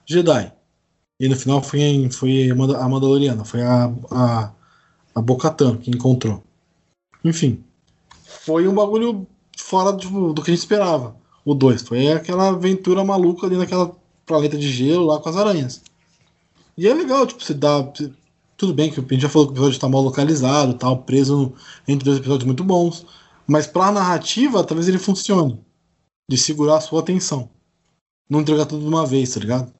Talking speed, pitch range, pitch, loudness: 180 wpm, 130-175 Hz, 150 Hz, -18 LUFS